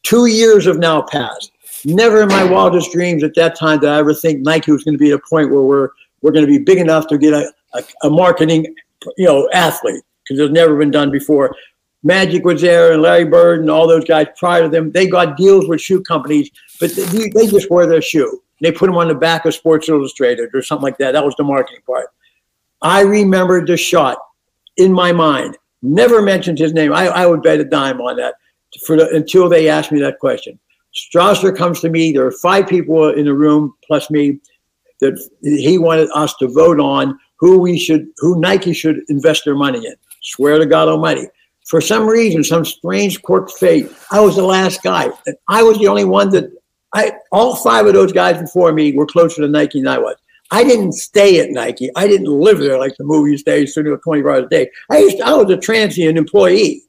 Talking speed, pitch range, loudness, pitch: 225 wpm, 150-190 Hz, -12 LUFS, 165 Hz